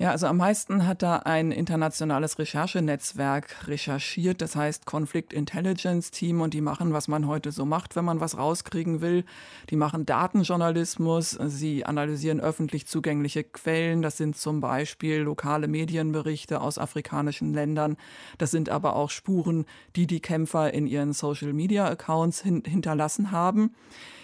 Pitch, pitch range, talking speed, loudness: 155 Hz, 150-170 Hz, 145 wpm, -27 LUFS